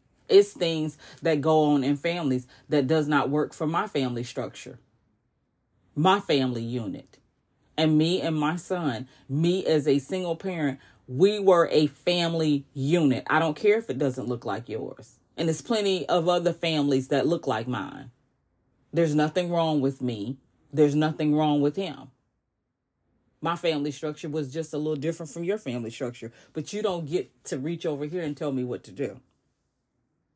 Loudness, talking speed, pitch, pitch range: -26 LUFS, 175 wpm, 150 Hz, 130-165 Hz